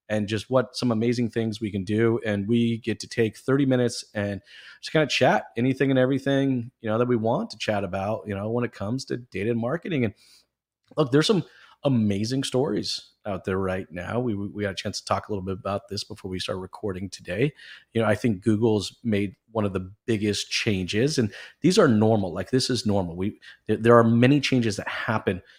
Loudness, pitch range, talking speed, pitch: -25 LUFS, 100-125 Hz, 225 wpm, 110 Hz